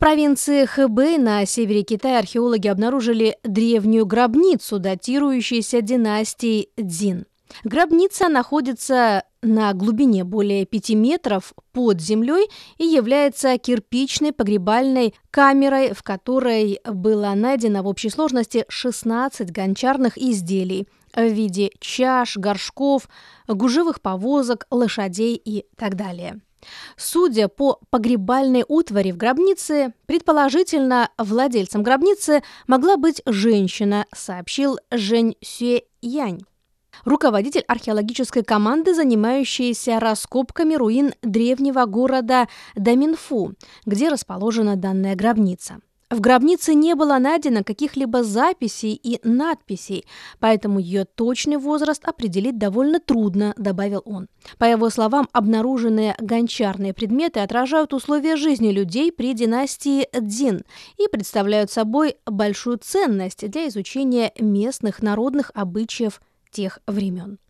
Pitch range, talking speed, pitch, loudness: 210-270 Hz, 105 wpm, 235 Hz, -20 LUFS